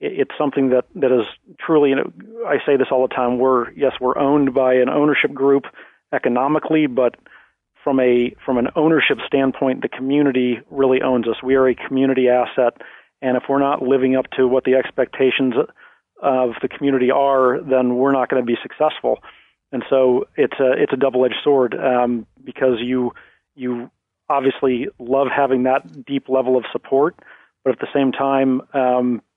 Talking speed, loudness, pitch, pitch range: 175 wpm, -18 LUFS, 130 Hz, 125-140 Hz